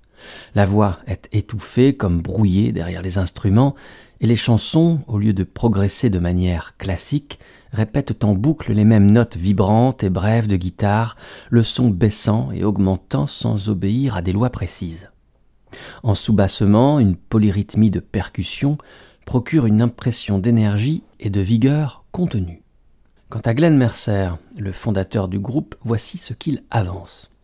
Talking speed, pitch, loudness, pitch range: 145 wpm, 105 Hz, -19 LUFS, 95-120 Hz